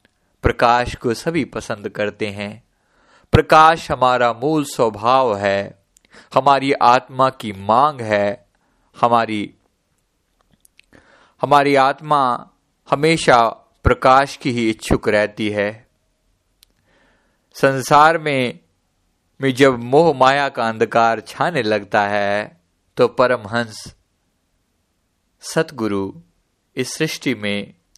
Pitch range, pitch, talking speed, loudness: 100-135 Hz, 115 Hz, 90 wpm, -17 LUFS